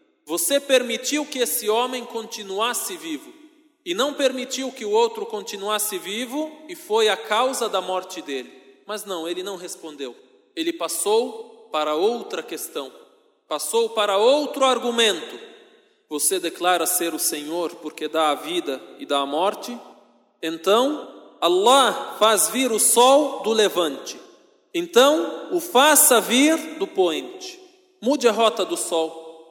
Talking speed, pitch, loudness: 140 wpm, 250 Hz, -21 LUFS